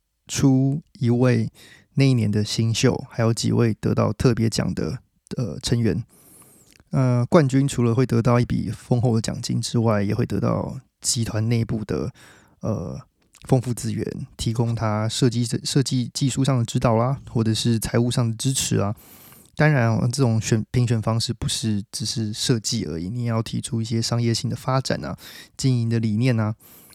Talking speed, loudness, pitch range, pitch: 255 characters per minute, -22 LUFS, 110-130 Hz, 120 Hz